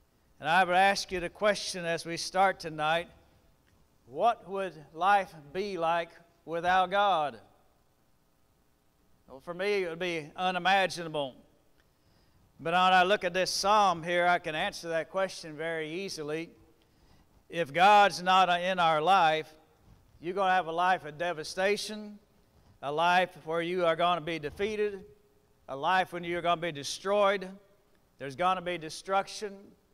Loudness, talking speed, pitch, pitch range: -29 LUFS, 150 wpm, 175 Hz, 160-195 Hz